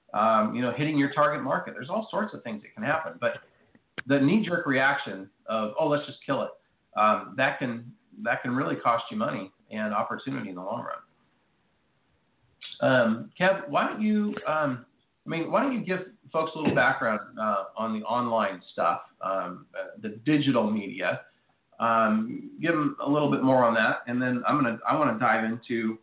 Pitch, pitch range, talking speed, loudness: 135 Hz, 115-160 Hz, 190 wpm, -27 LUFS